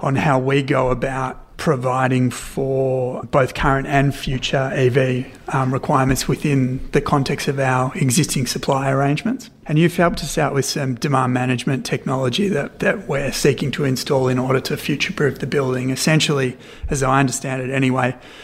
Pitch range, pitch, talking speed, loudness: 130-145 Hz, 135 Hz, 165 wpm, -19 LUFS